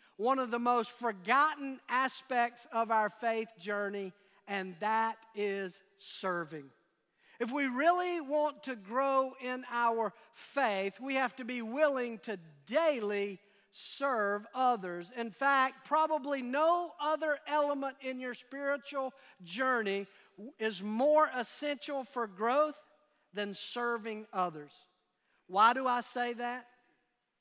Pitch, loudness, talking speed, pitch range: 245 Hz, -33 LUFS, 120 wpm, 205-275 Hz